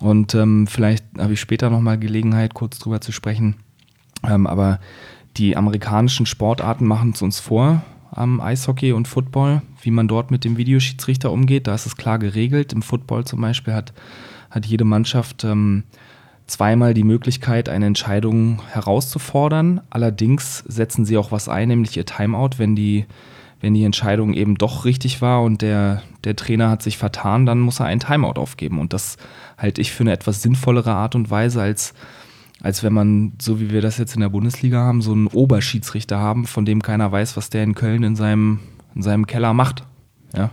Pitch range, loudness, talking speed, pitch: 105-125 Hz, -18 LUFS, 190 wpm, 115 Hz